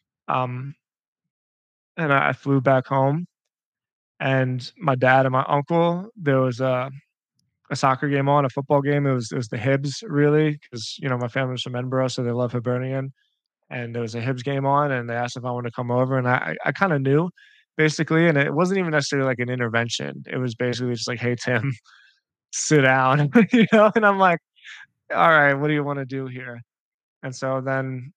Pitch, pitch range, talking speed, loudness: 135 Hz, 125-145 Hz, 205 wpm, -22 LUFS